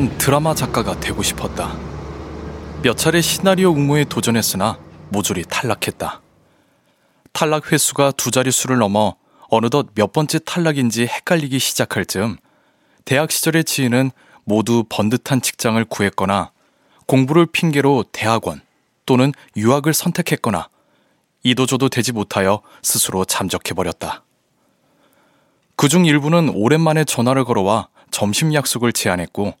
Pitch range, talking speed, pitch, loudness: 105-150 Hz, 295 characters per minute, 125 Hz, -17 LUFS